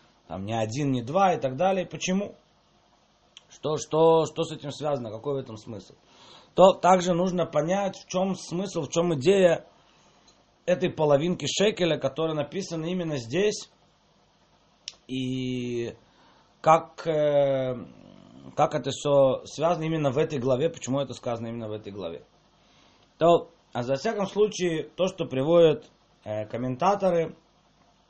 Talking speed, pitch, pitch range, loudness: 130 wpm, 155 Hz, 130-180 Hz, -26 LUFS